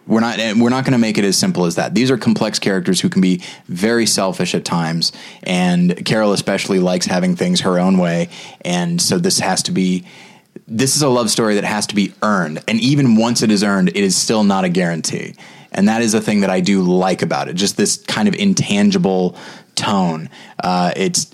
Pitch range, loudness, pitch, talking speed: 90-125 Hz, -16 LUFS, 105 Hz, 220 wpm